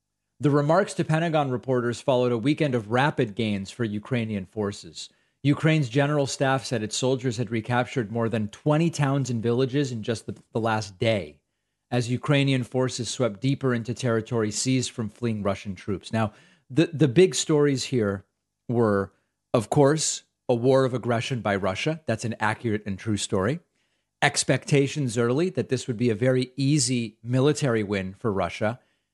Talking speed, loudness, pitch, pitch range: 165 wpm, -25 LUFS, 125 Hz, 110-140 Hz